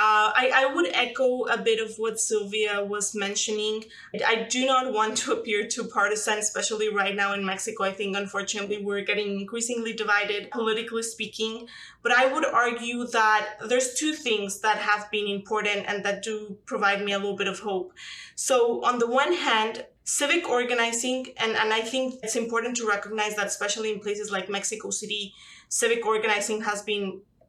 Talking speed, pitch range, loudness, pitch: 180 wpm, 205-235 Hz, -25 LUFS, 215 Hz